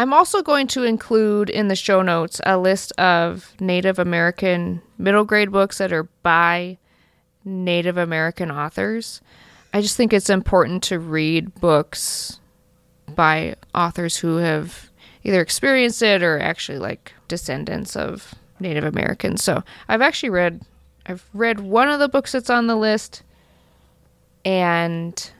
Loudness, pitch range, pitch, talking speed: -19 LUFS, 165-210 Hz, 180 Hz, 140 wpm